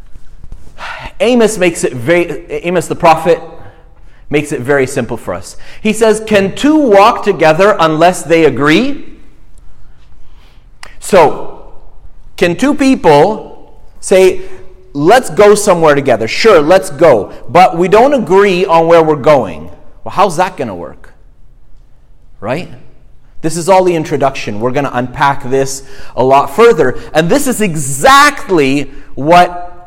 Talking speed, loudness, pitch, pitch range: 135 wpm, -10 LUFS, 175 Hz, 145-210 Hz